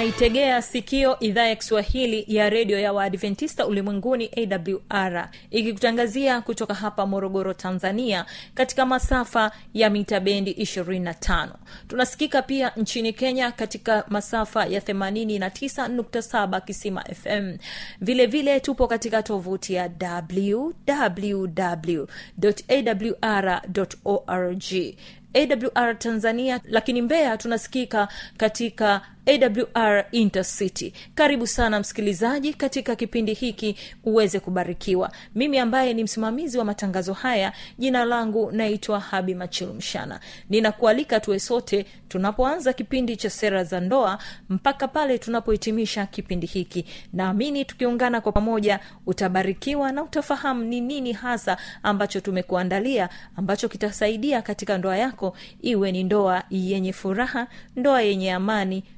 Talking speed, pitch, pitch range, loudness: 110 wpm, 215 Hz, 195-245 Hz, -24 LUFS